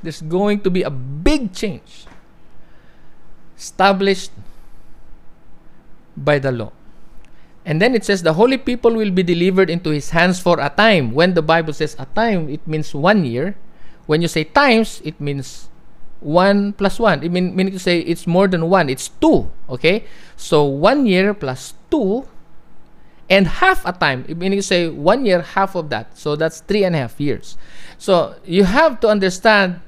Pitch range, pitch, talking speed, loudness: 155-200 Hz, 180 Hz, 175 wpm, -17 LUFS